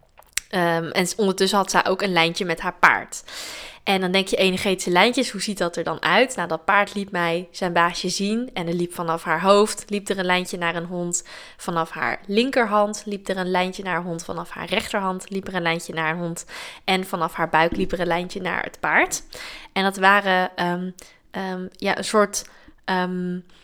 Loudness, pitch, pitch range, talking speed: -22 LUFS, 185 Hz, 170-195 Hz, 215 wpm